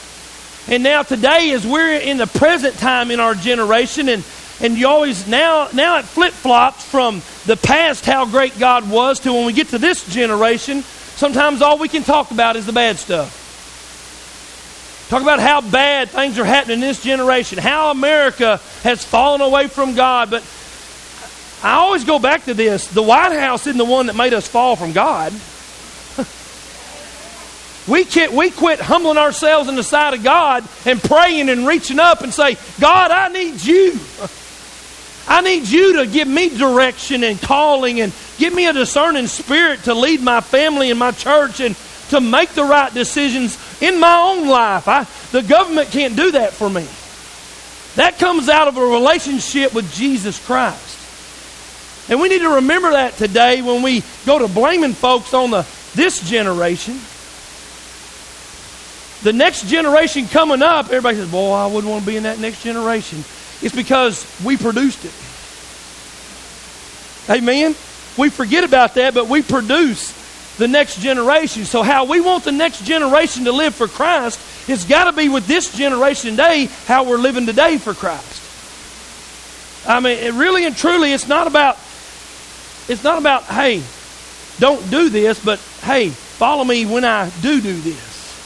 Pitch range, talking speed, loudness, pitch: 230-295 Hz, 170 wpm, -14 LUFS, 260 Hz